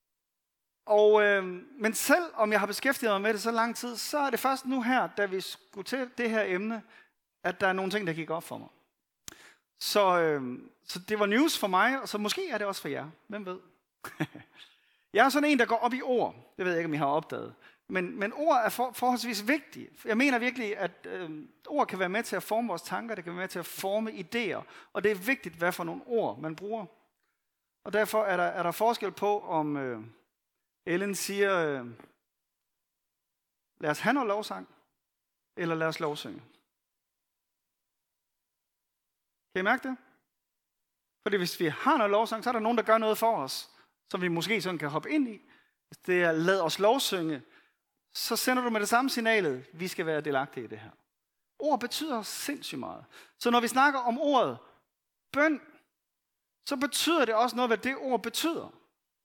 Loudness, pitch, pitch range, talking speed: -29 LUFS, 210 Hz, 180-245 Hz, 205 wpm